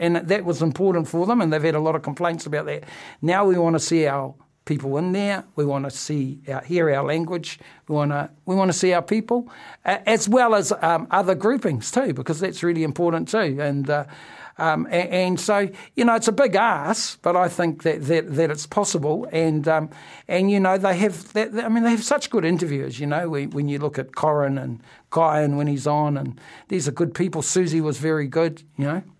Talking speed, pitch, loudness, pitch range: 235 wpm, 165 Hz, -22 LUFS, 150-190 Hz